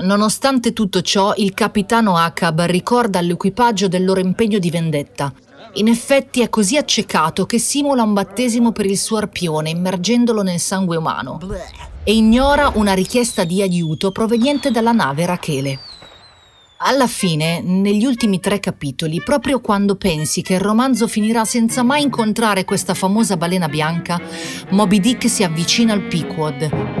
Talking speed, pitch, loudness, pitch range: 145 wpm, 200 Hz, -16 LUFS, 175-230 Hz